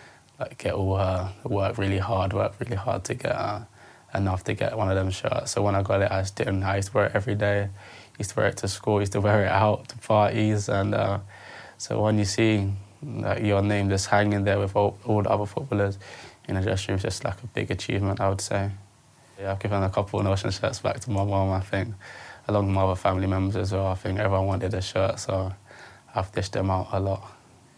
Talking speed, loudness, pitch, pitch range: 245 wpm, -26 LUFS, 100 Hz, 95-105 Hz